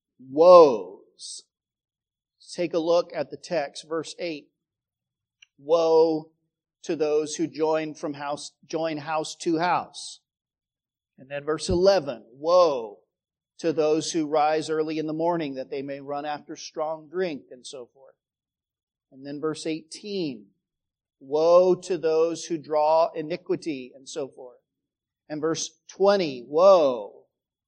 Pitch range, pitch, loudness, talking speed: 155-180 Hz, 160 Hz, -24 LUFS, 130 wpm